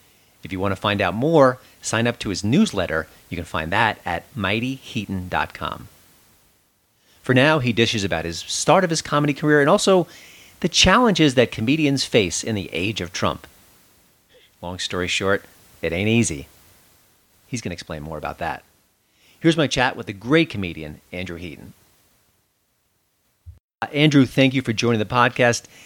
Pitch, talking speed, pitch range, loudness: 110 Hz, 165 wpm, 90-135 Hz, -20 LUFS